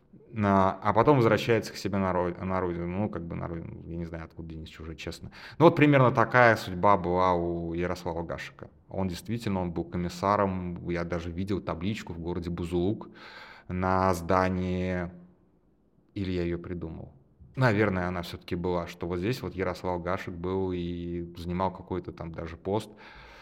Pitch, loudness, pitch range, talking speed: 90 Hz, -28 LUFS, 85-100 Hz, 160 wpm